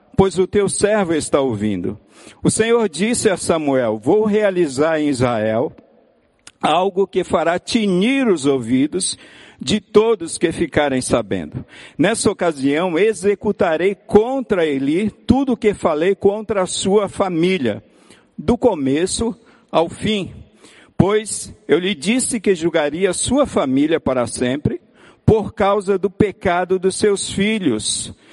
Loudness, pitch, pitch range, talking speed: -18 LUFS, 195 Hz, 160-215 Hz, 125 wpm